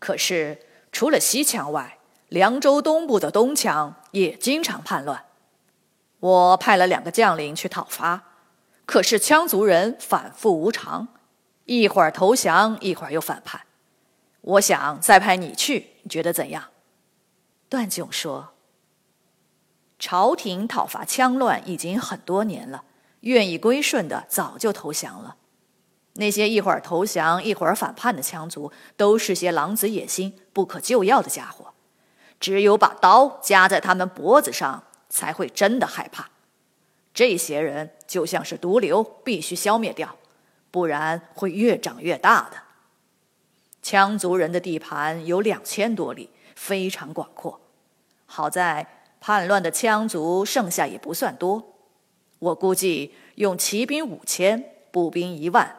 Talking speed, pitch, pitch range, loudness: 205 characters per minute, 195 Hz, 175-220 Hz, -21 LUFS